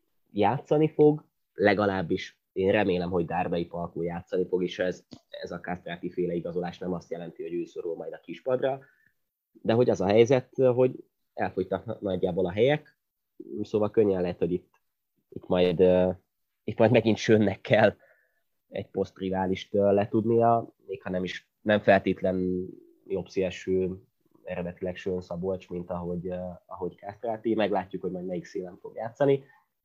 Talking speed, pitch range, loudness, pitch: 145 wpm, 90-115 Hz, -27 LUFS, 95 Hz